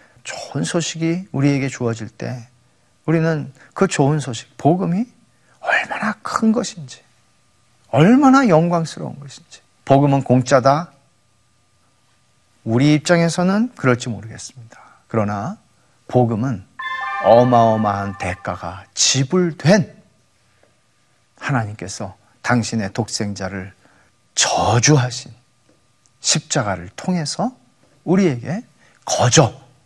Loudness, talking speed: -18 LUFS, 220 characters per minute